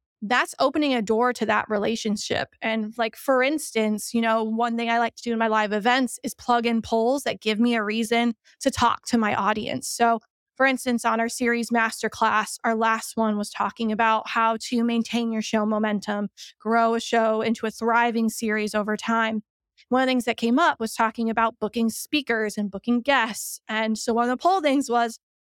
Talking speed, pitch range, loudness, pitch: 205 wpm, 220-240 Hz, -23 LUFS, 230 Hz